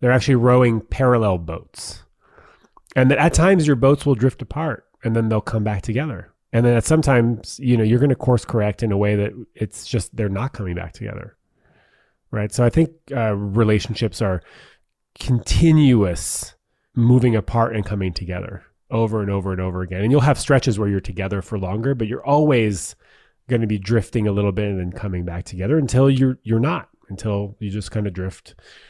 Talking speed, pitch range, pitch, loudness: 195 wpm, 100-125 Hz, 115 Hz, -20 LUFS